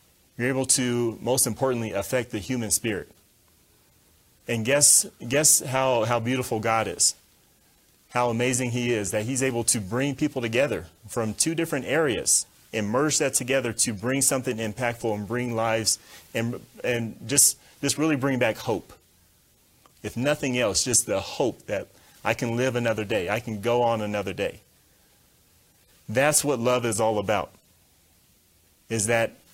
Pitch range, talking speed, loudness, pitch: 110-130 Hz, 155 wpm, -24 LUFS, 120 Hz